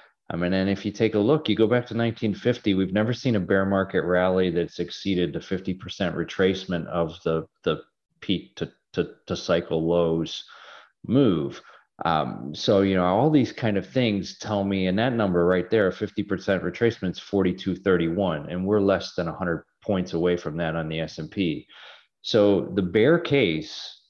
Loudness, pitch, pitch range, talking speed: -24 LUFS, 95 Hz, 90-105 Hz, 180 wpm